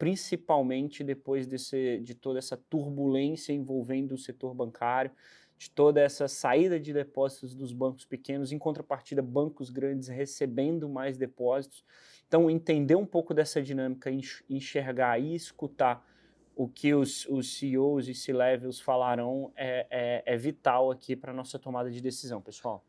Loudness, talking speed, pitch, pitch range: -31 LUFS, 145 wpm, 135 Hz, 130-145 Hz